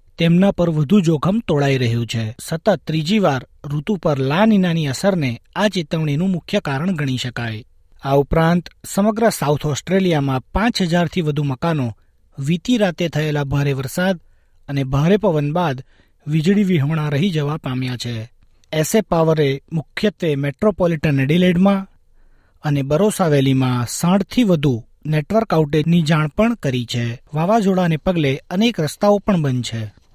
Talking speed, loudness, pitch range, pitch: 130 wpm, -18 LUFS, 140-190 Hz, 155 Hz